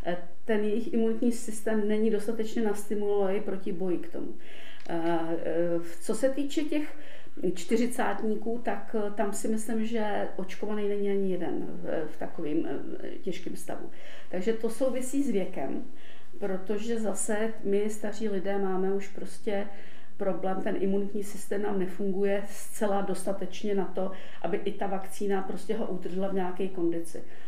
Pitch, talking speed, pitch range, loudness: 205 Hz, 135 wpm, 190-225 Hz, -32 LUFS